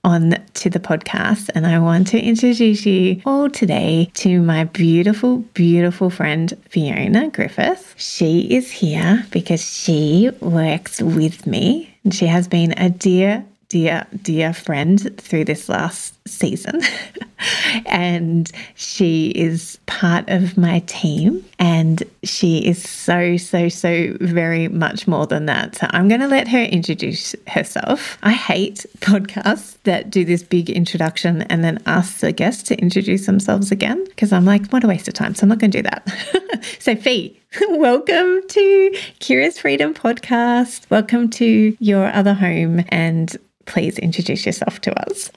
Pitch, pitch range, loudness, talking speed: 190 Hz, 170-220 Hz, -17 LUFS, 150 wpm